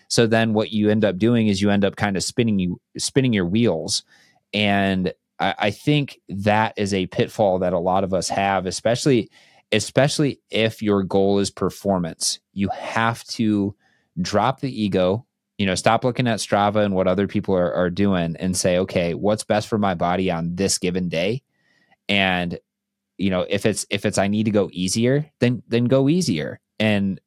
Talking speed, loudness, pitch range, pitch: 190 wpm, -21 LUFS, 95-115 Hz, 105 Hz